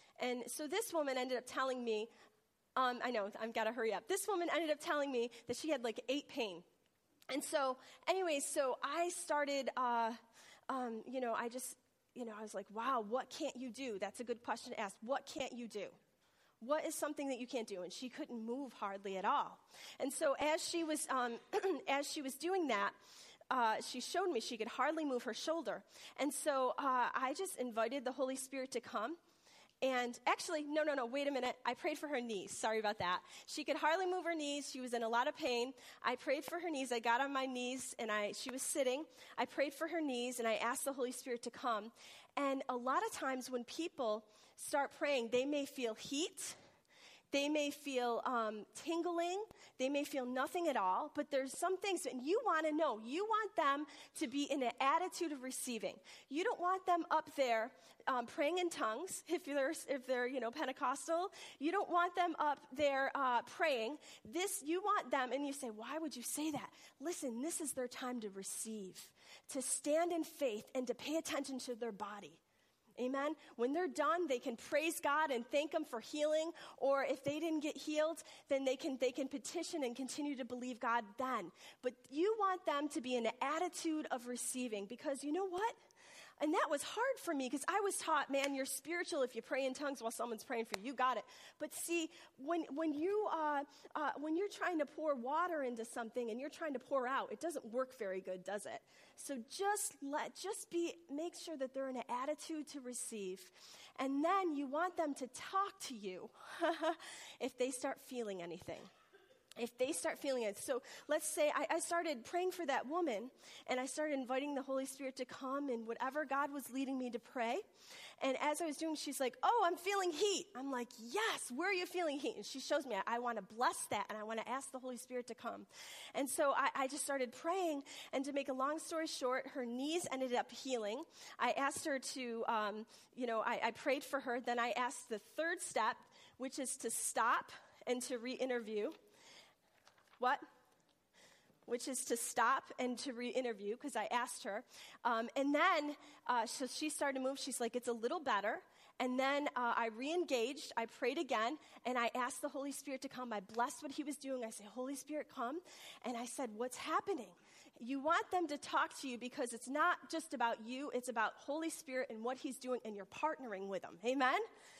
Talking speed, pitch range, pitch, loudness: 215 wpm, 245-310 Hz, 270 Hz, -40 LUFS